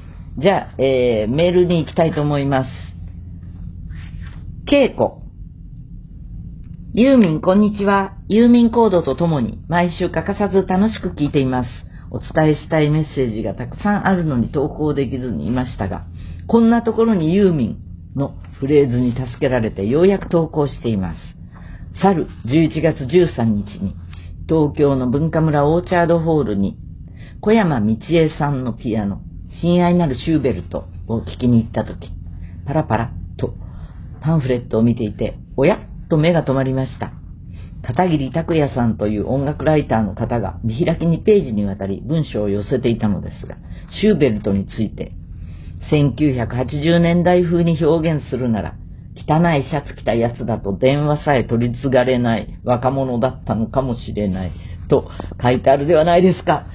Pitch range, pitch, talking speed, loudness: 100-160 Hz, 130 Hz, 320 characters per minute, -18 LUFS